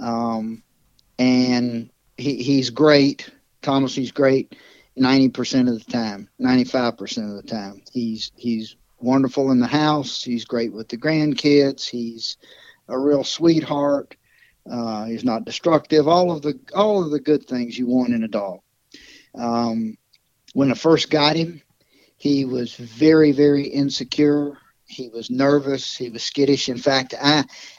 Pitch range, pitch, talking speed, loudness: 120-145 Hz, 130 Hz, 150 wpm, -20 LUFS